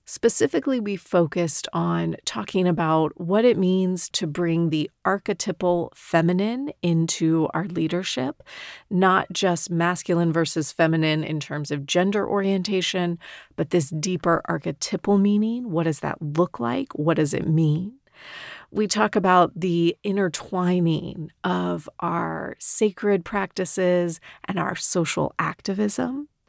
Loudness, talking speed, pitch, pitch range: -23 LUFS, 120 wpm, 175 Hz, 165-195 Hz